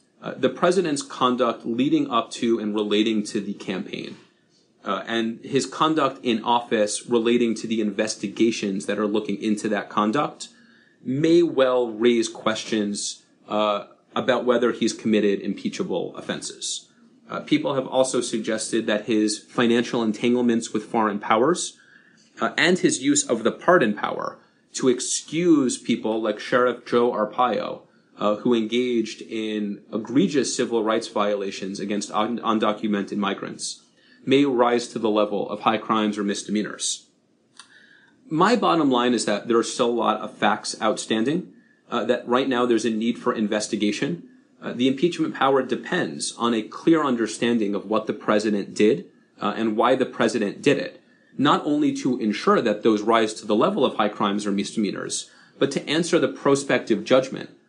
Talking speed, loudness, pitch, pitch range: 160 wpm, -23 LUFS, 115 Hz, 105-125 Hz